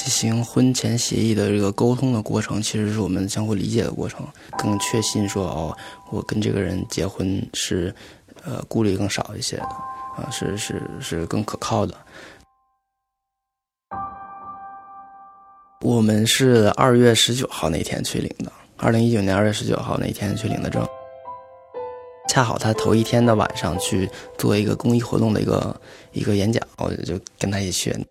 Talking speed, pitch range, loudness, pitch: 250 characters per minute, 105-155 Hz, -21 LUFS, 115 Hz